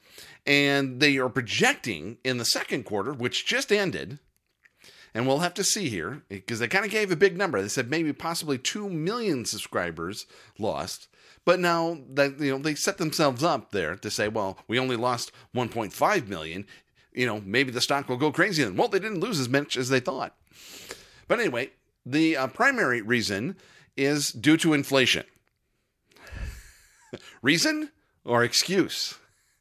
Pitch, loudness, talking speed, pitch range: 140 Hz, -26 LUFS, 165 wpm, 125-170 Hz